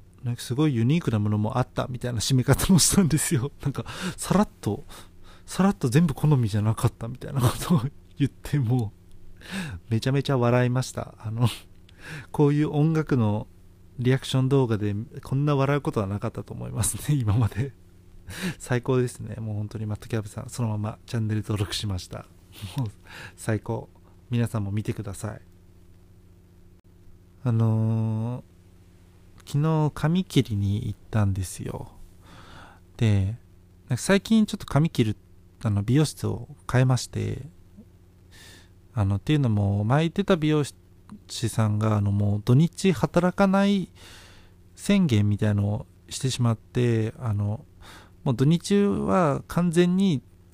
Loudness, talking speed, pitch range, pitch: -25 LUFS, 285 characters per minute, 95-135 Hz, 110 Hz